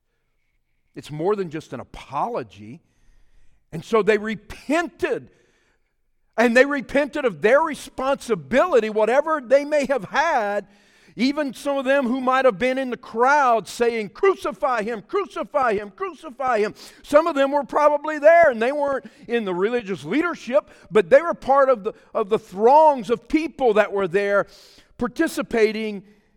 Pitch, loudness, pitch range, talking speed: 245 Hz, -21 LUFS, 210-290 Hz, 155 wpm